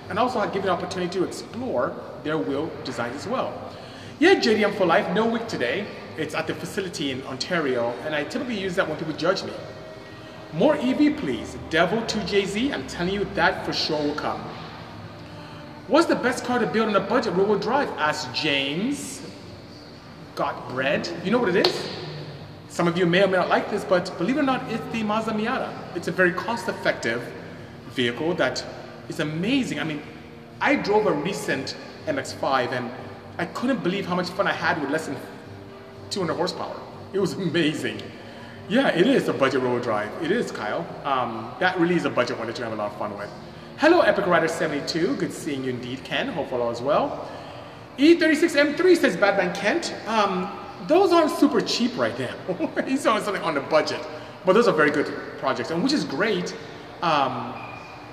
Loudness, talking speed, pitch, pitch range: -24 LUFS, 190 wpm, 185 Hz, 150-230 Hz